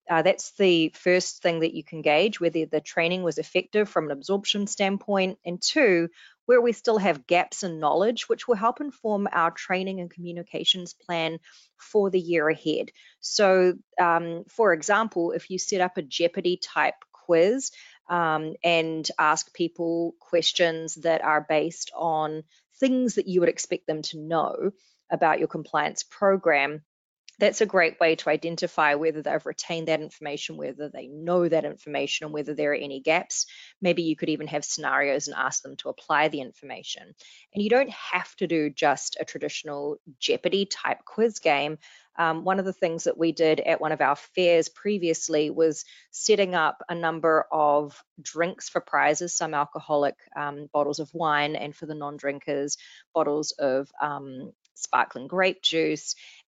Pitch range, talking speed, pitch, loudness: 155-185 Hz, 170 wpm, 165 Hz, -25 LUFS